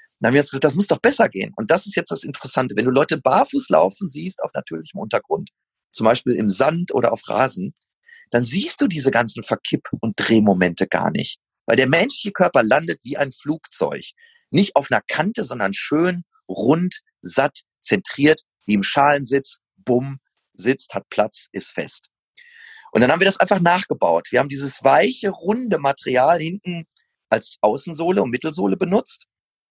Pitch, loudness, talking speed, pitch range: 155 Hz, -19 LUFS, 175 wpm, 130-205 Hz